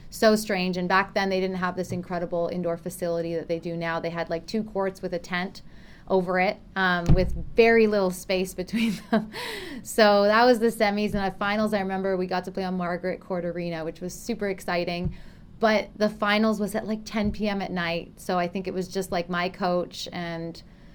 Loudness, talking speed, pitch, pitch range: -26 LUFS, 215 wpm, 185 Hz, 175-210 Hz